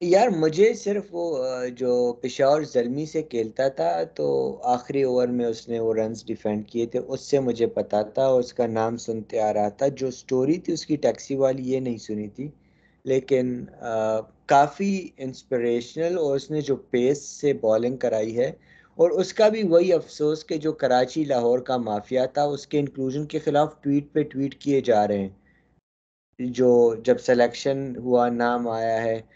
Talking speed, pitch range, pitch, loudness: 180 wpm, 120-150 Hz, 130 Hz, -24 LUFS